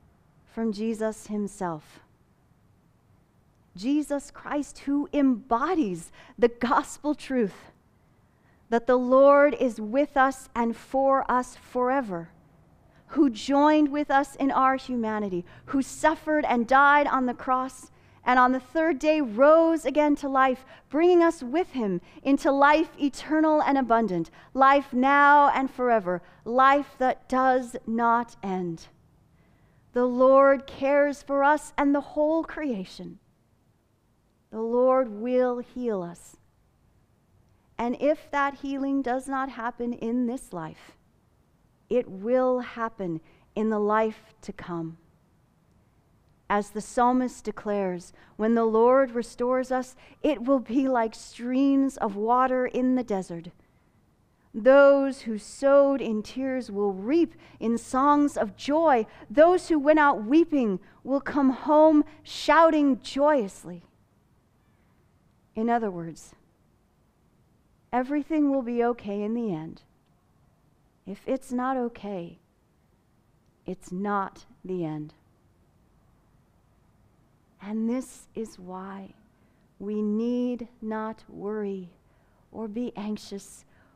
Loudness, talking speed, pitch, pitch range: -25 LUFS, 115 wpm, 250 Hz, 215-275 Hz